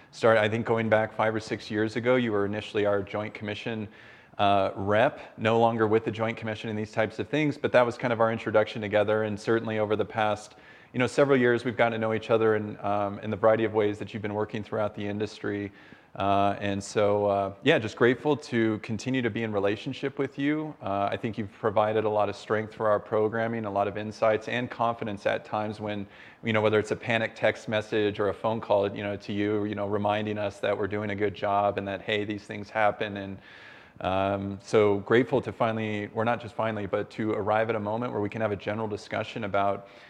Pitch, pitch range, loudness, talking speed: 110 Hz, 105-115 Hz, -27 LUFS, 235 wpm